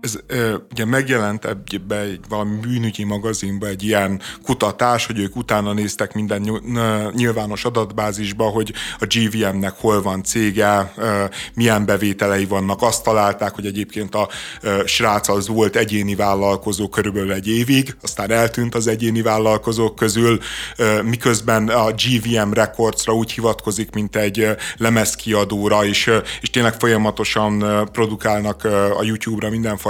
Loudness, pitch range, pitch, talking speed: -18 LUFS, 105-115 Hz, 110 Hz, 125 wpm